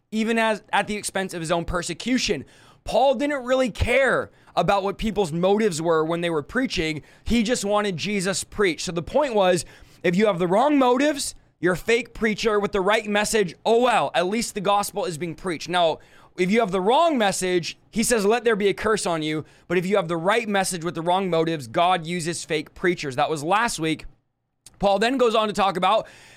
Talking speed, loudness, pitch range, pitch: 220 wpm, -22 LUFS, 170-220 Hz, 195 Hz